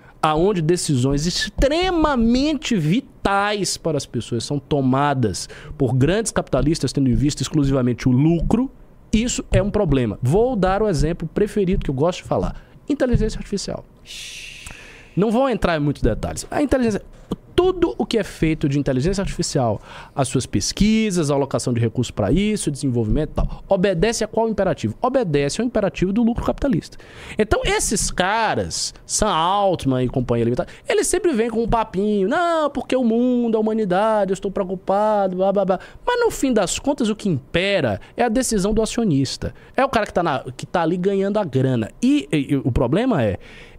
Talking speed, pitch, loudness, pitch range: 175 wpm, 190 Hz, -20 LUFS, 140-225 Hz